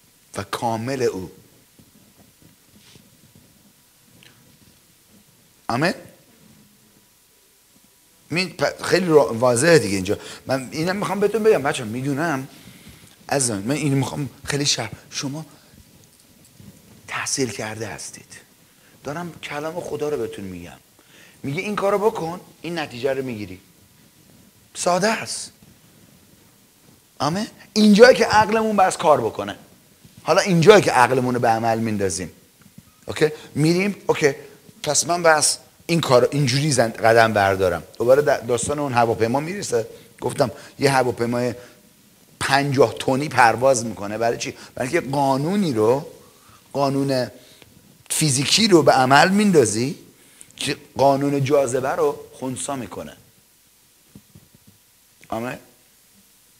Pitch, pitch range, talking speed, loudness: 140 Hz, 120-165 Hz, 105 wpm, -20 LUFS